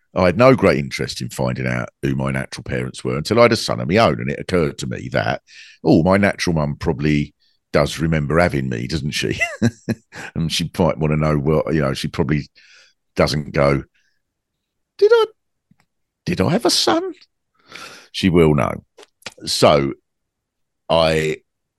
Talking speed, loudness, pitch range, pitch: 175 wpm, -18 LUFS, 70-95 Hz, 80 Hz